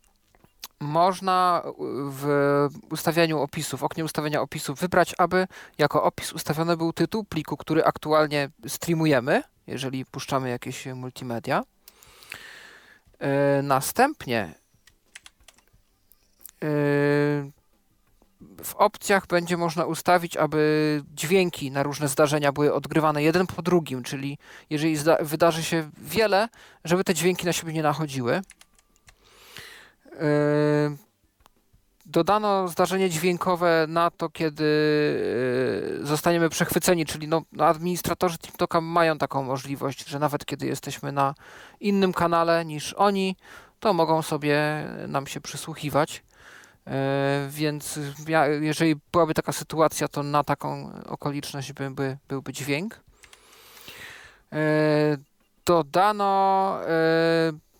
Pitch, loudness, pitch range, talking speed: 155 Hz, -24 LUFS, 145-170 Hz, 100 wpm